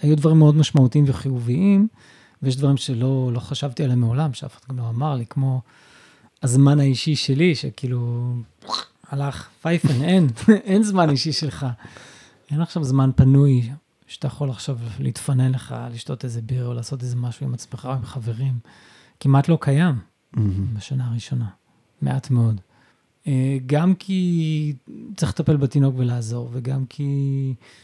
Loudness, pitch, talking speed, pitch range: -21 LUFS, 135 Hz, 140 wpm, 125-150 Hz